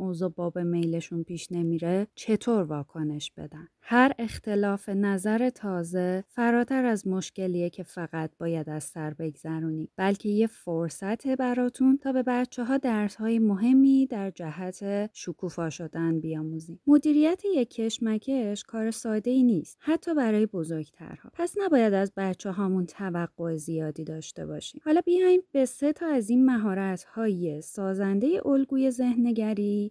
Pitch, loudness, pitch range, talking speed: 200 Hz, -27 LUFS, 170-245 Hz, 135 wpm